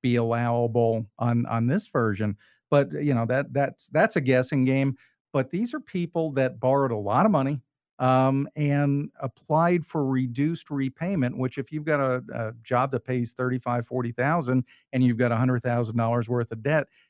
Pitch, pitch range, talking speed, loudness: 130 Hz, 120-145 Hz, 185 wpm, -25 LUFS